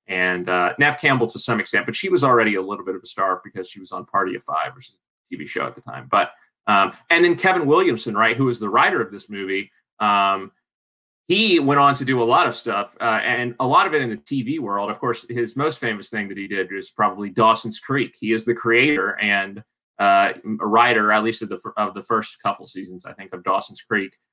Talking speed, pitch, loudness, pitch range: 250 wpm, 115 Hz, -20 LUFS, 100-120 Hz